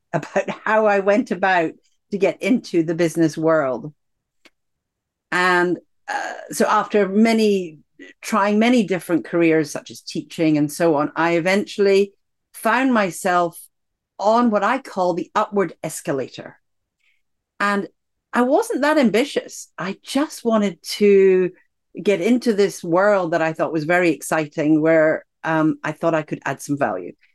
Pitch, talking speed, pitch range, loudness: 185 Hz, 145 wpm, 160-210 Hz, -19 LUFS